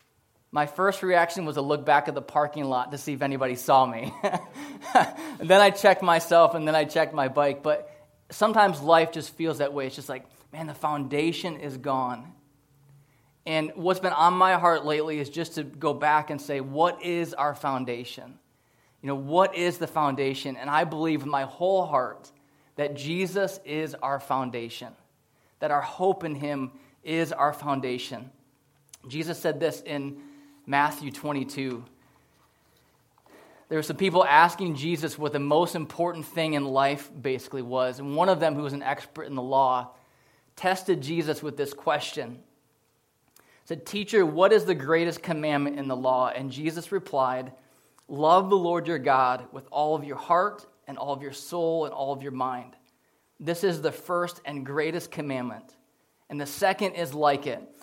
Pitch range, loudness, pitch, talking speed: 140-170 Hz, -26 LUFS, 150 Hz, 175 wpm